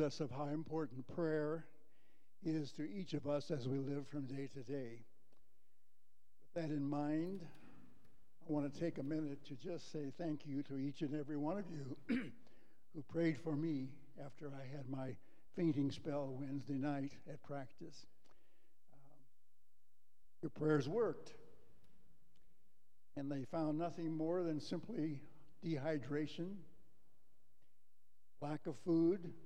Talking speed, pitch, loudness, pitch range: 140 wpm, 150 Hz, -43 LUFS, 140-160 Hz